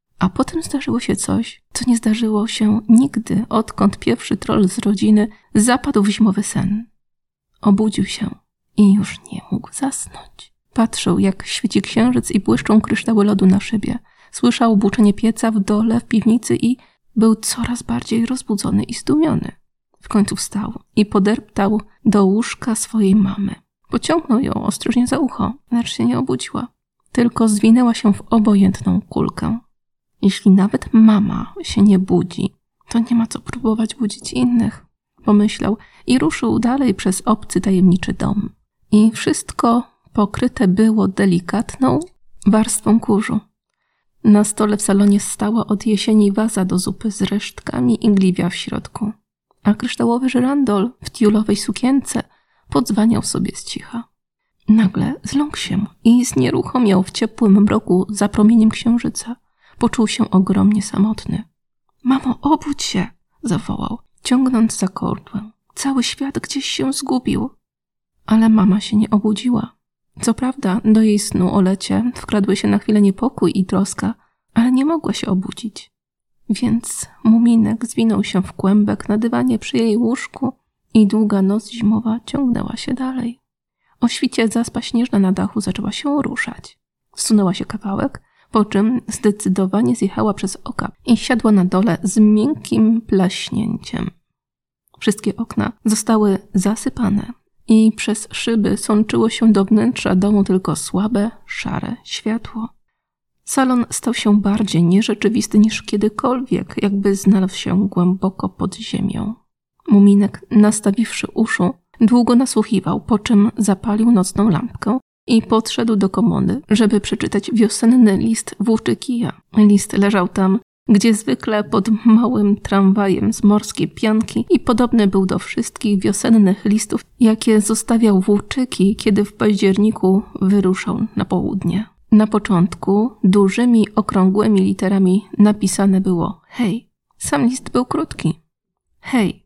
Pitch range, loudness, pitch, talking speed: 200-235 Hz, -17 LUFS, 215 Hz, 135 wpm